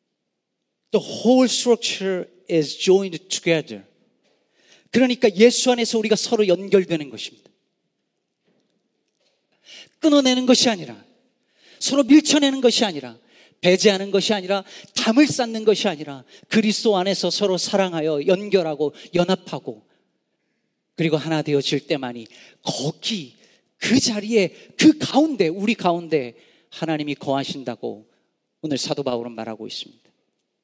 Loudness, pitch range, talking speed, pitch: -20 LUFS, 155-230 Hz, 320 characters per minute, 195 Hz